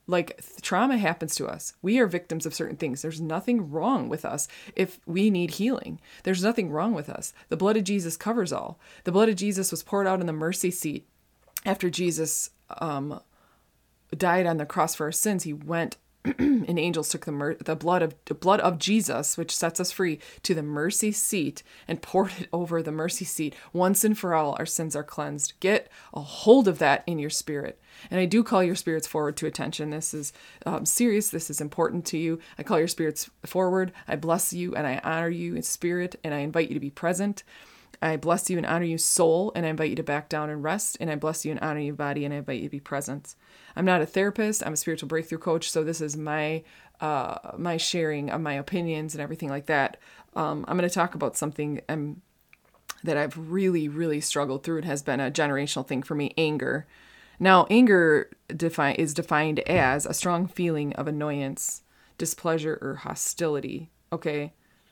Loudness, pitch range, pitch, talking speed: -26 LUFS, 150-185 Hz, 165 Hz, 210 wpm